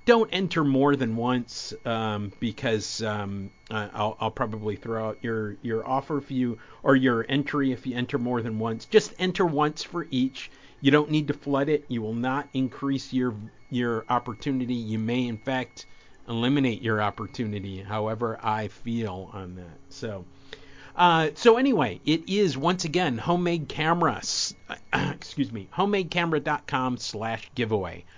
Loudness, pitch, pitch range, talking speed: -26 LUFS, 125 Hz, 110-145 Hz, 155 wpm